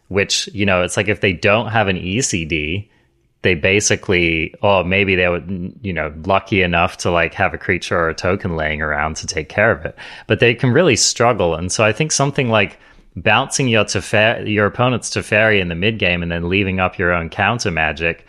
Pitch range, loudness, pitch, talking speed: 85-110 Hz, -16 LUFS, 95 Hz, 215 wpm